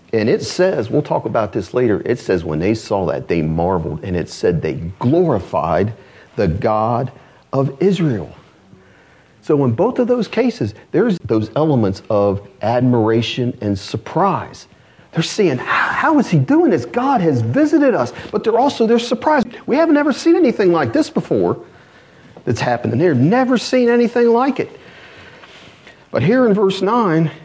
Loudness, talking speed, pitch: -16 LUFS, 170 wpm, 165 Hz